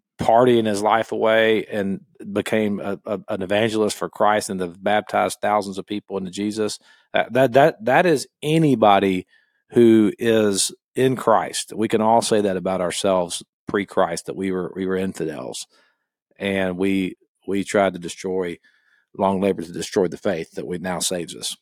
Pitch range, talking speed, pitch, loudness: 95-110 Hz, 170 wpm, 100 Hz, -21 LUFS